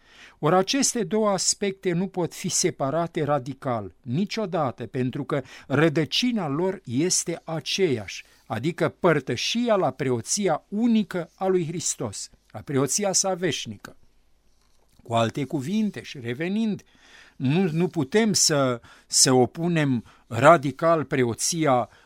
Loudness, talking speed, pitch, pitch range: -24 LUFS, 110 wpm, 165 Hz, 130-190 Hz